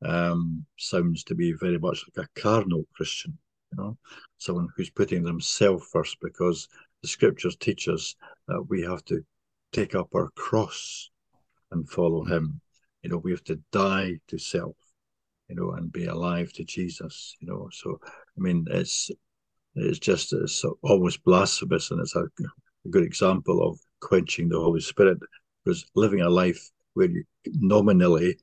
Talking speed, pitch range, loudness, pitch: 160 wpm, 85-90 Hz, -26 LUFS, 85 Hz